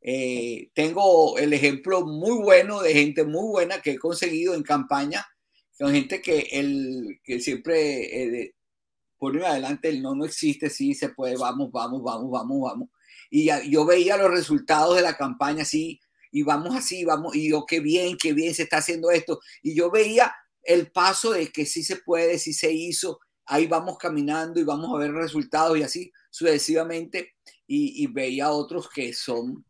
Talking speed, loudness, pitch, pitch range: 180 wpm, -23 LUFS, 165 Hz, 150-185 Hz